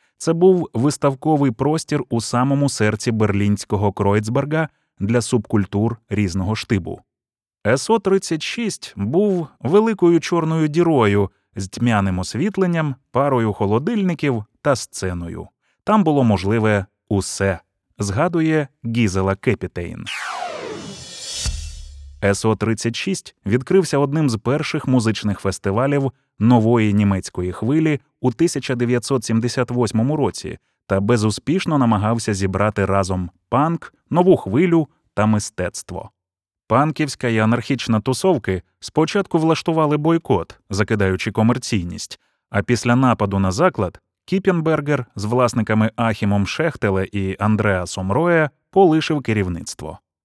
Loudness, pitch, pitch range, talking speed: -19 LUFS, 120 Hz, 100-150 Hz, 95 wpm